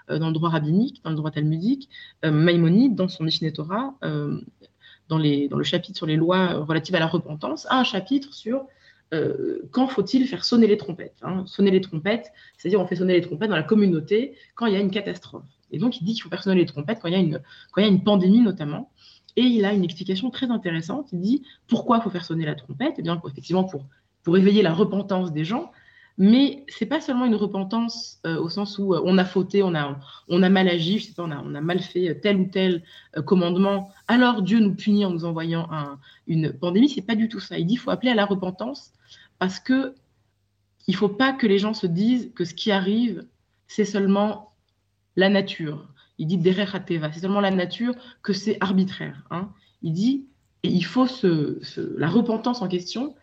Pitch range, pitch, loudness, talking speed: 170-225 Hz, 190 Hz, -23 LUFS, 220 wpm